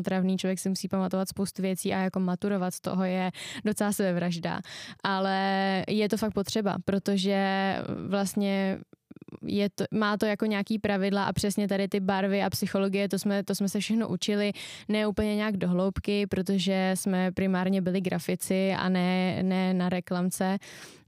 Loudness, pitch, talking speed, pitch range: -28 LUFS, 195 Hz, 165 wpm, 185-205 Hz